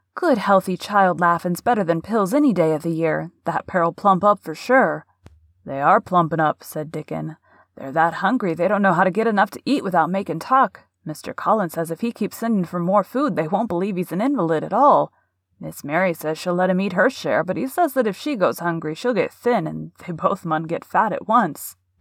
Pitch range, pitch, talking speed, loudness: 160-210 Hz, 180 Hz, 230 wpm, -20 LUFS